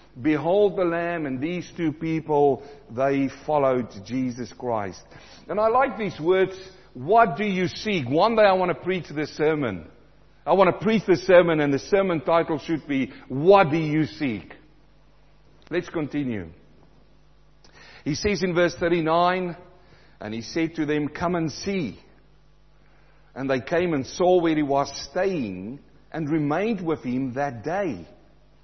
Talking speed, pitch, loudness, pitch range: 155 wpm, 160 Hz, -23 LUFS, 135-180 Hz